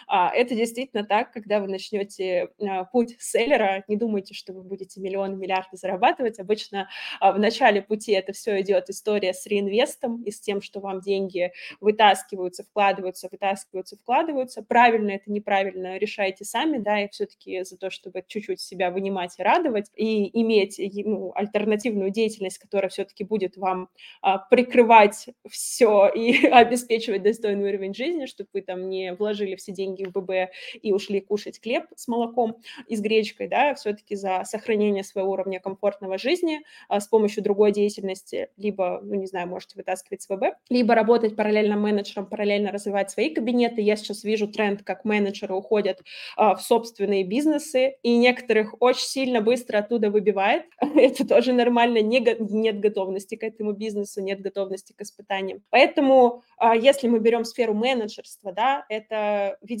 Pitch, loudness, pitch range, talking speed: 210 Hz, -23 LUFS, 195-230 Hz, 160 wpm